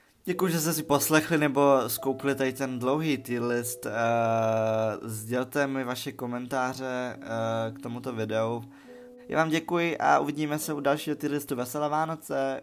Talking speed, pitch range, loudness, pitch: 145 wpm, 120-150 Hz, -28 LUFS, 135 Hz